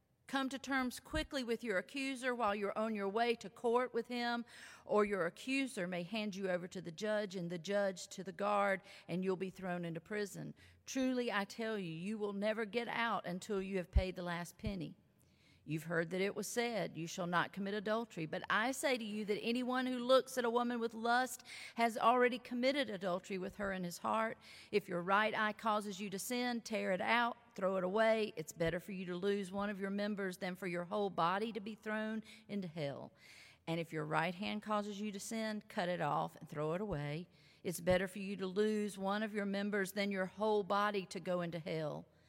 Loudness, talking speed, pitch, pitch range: -38 LUFS, 220 wpm, 205 Hz, 185-225 Hz